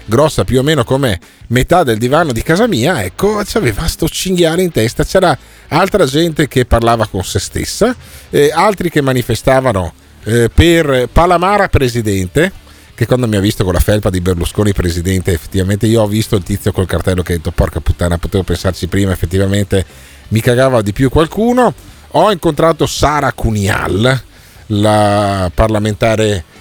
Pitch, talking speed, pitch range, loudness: 110 Hz, 165 wpm, 95-135 Hz, -13 LUFS